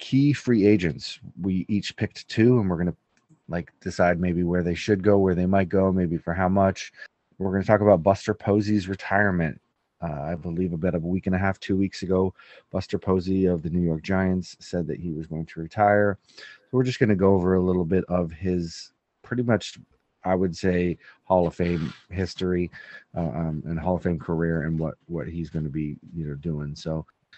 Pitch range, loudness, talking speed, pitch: 85-95 Hz, -25 LUFS, 220 wpm, 90 Hz